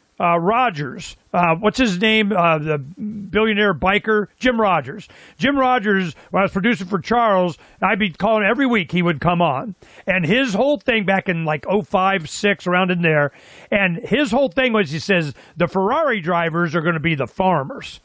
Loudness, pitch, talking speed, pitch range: -18 LUFS, 195 Hz, 190 wpm, 175-220 Hz